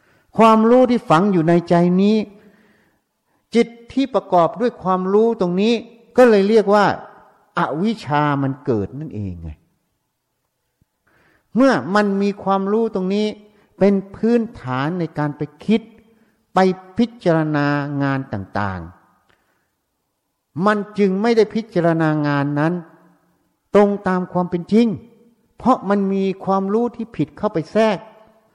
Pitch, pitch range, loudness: 195 Hz, 160-220 Hz, -18 LUFS